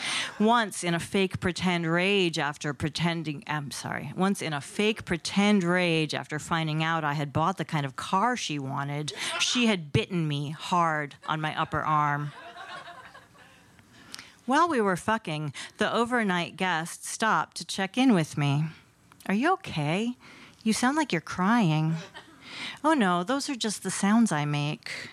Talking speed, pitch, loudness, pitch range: 160 wpm, 175 Hz, -27 LUFS, 155-215 Hz